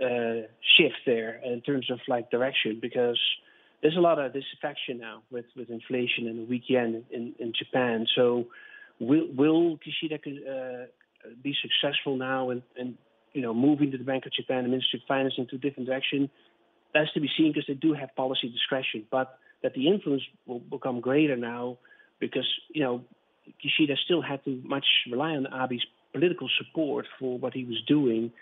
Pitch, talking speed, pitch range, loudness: 130 Hz, 185 wpm, 125-145 Hz, -27 LUFS